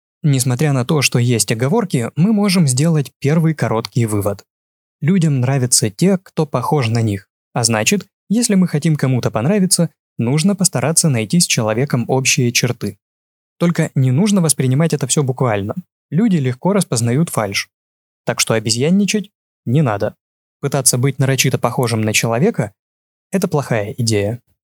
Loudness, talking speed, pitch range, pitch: -16 LUFS, 140 wpm, 115-165 Hz, 135 Hz